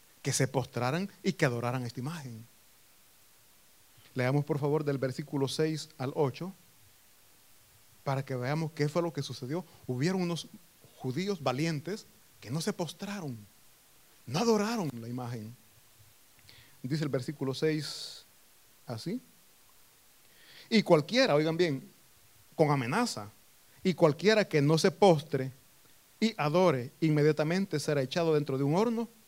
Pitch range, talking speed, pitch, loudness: 125-170 Hz, 125 wpm, 145 Hz, -31 LUFS